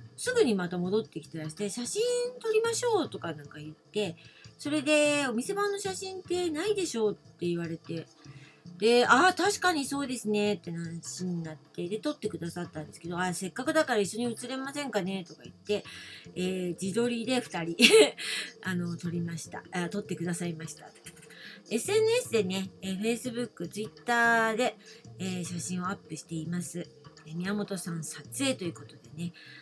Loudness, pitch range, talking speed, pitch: -30 LUFS, 165-250 Hz, 370 characters per minute, 190 Hz